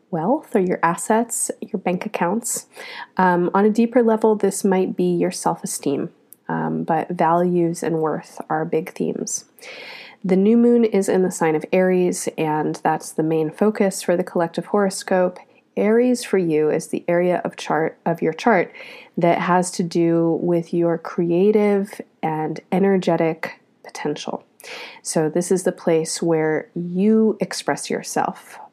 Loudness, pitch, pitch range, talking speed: -20 LUFS, 180 Hz, 165-210 Hz, 150 wpm